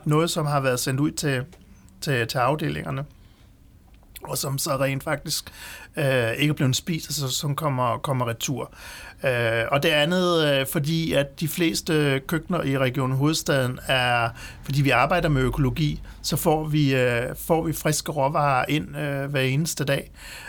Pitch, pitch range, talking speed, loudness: 140 Hz, 130-155 Hz, 175 wpm, -23 LUFS